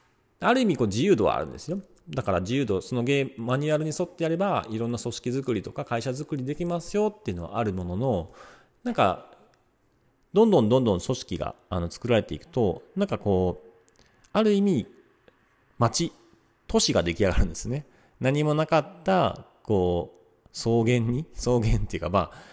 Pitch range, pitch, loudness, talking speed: 105-155 Hz, 125 Hz, -26 LUFS, 355 characters per minute